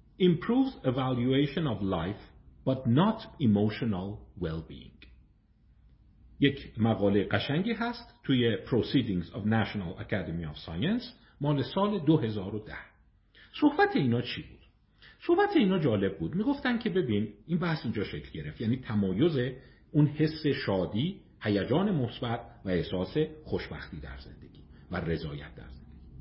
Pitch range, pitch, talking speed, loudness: 100-160 Hz, 120 Hz, 125 wpm, -30 LUFS